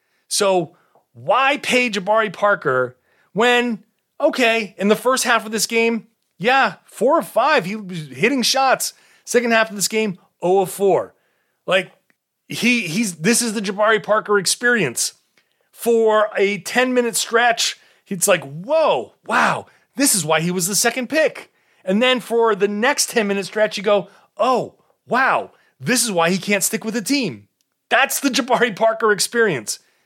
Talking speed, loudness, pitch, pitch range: 165 wpm, -18 LUFS, 220 Hz, 195-240 Hz